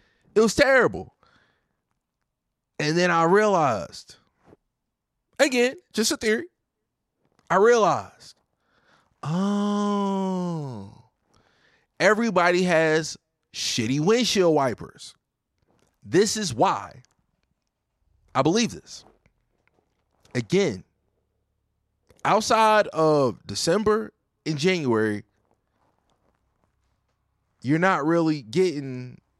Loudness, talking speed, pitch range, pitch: -22 LUFS, 70 wpm, 125-205 Hz, 170 Hz